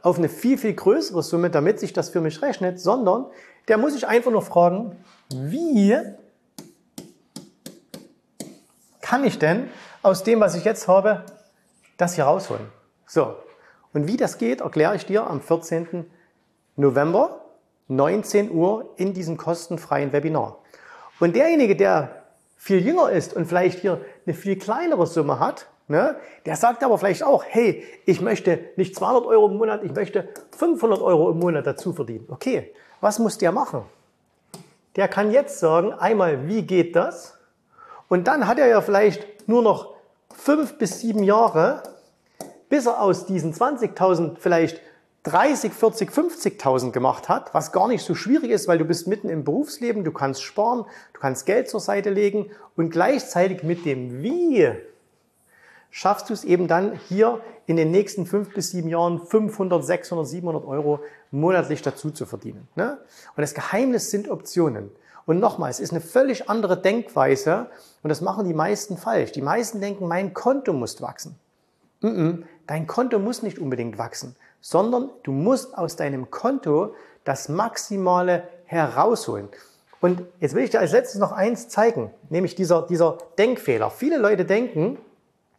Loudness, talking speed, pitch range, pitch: -22 LUFS, 160 wpm, 165-225 Hz, 190 Hz